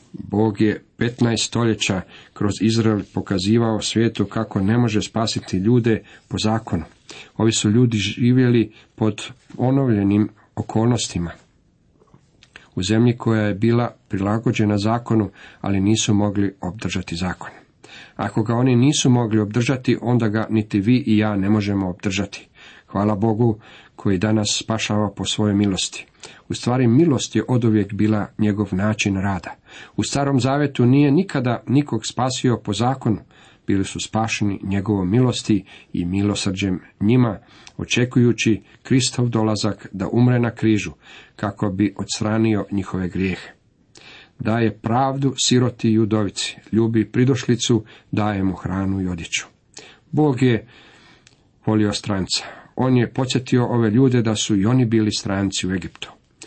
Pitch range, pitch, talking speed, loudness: 100-120 Hz, 110 Hz, 130 wpm, -20 LUFS